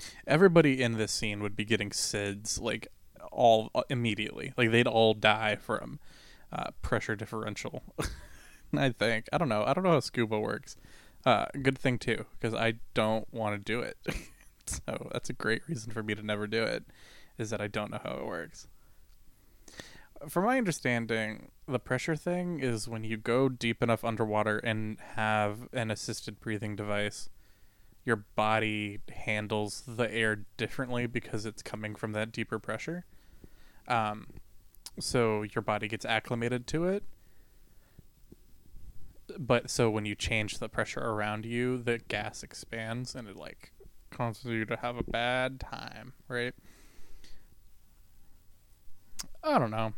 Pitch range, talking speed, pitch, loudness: 105-120 Hz, 150 wpm, 110 Hz, -31 LUFS